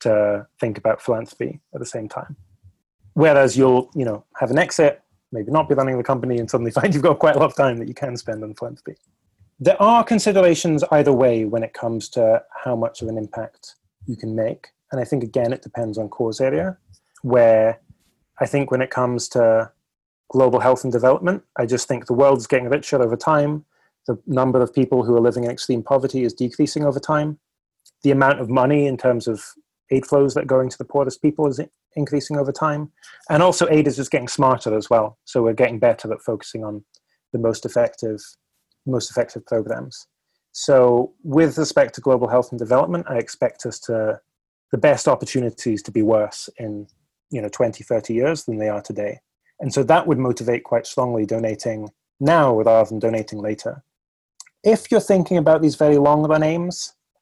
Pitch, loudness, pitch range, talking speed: 125 Hz, -19 LUFS, 115-145 Hz, 200 wpm